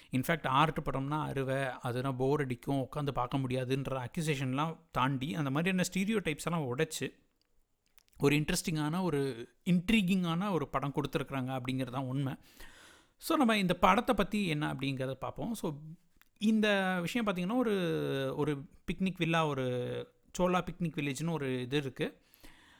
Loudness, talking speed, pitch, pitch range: -33 LUFS, 130 wpm, 150 Hz, 135-180 Hz